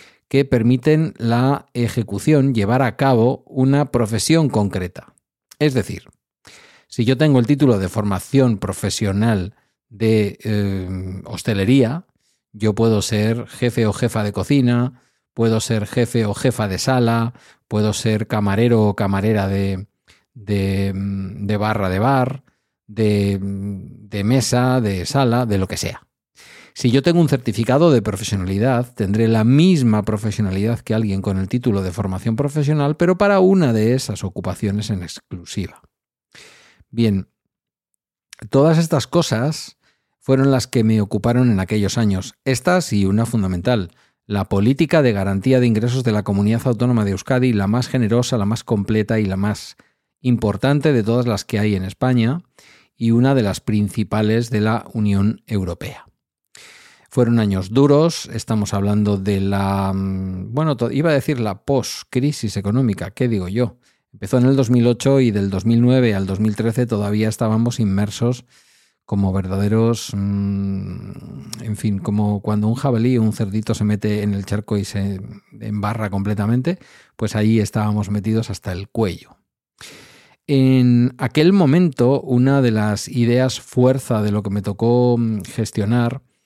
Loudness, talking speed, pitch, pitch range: -18 LUFS, 145 wpm, 110 Hz, 100-125 Hz